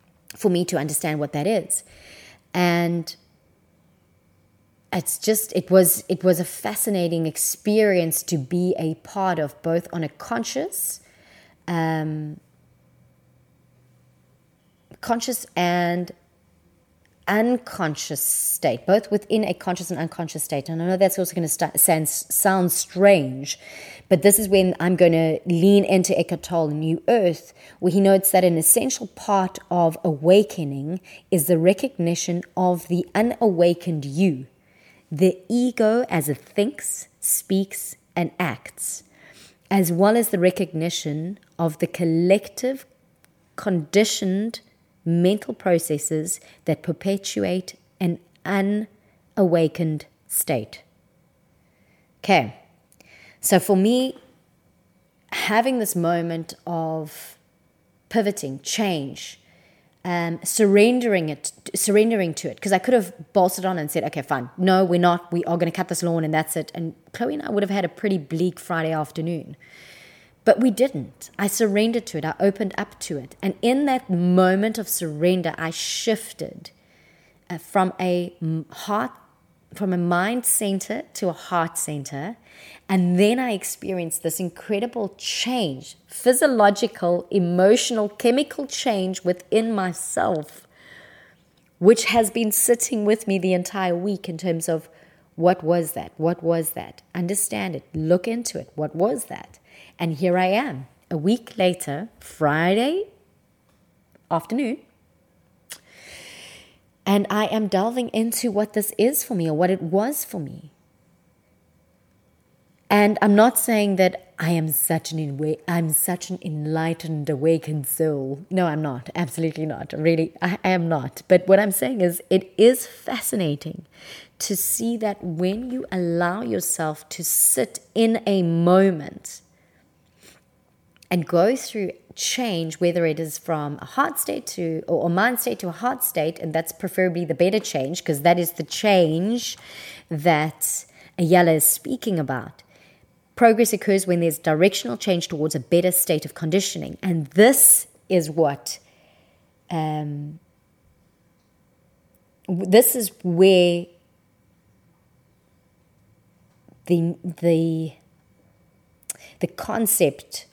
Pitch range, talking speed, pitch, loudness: 160-200 Hz, 130 wpm, 180 Hz, -21 LUFS